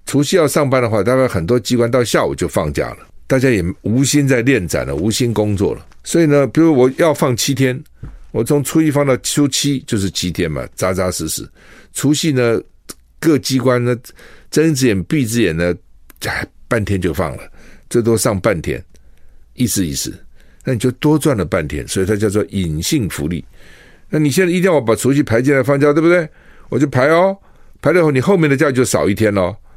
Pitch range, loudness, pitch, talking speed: 105-145 Hz, -15 LUFS, 125 Hz, 295 characters per minute